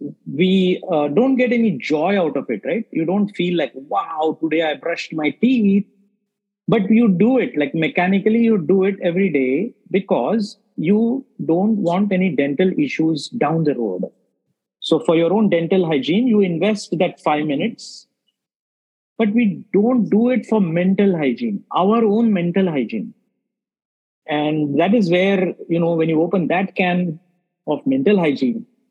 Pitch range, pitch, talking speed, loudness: 165-220 Hz, 190 Hz, 160 wpm, -18 LUFS